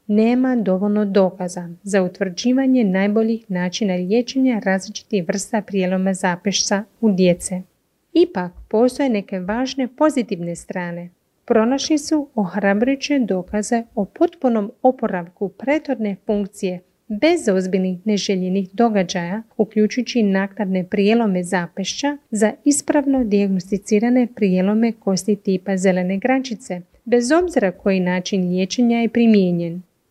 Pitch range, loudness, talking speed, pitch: 190-240 Hz, -19 LUFS, 105 wpm, 205 Hz